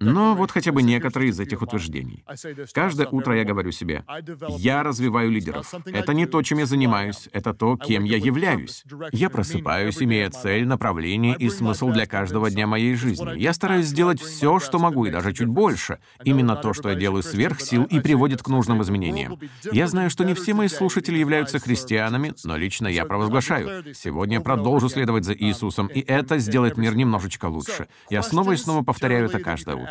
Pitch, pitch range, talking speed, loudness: 120 Hz, 105-145 Hz, 185 wpm, -22 LUFS